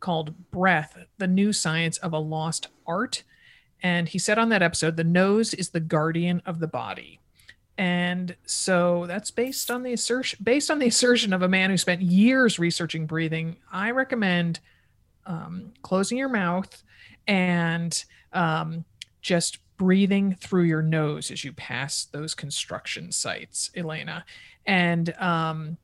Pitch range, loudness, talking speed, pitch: 165-195 Hz, -25 LUFS, 150 wpm, 175 Hz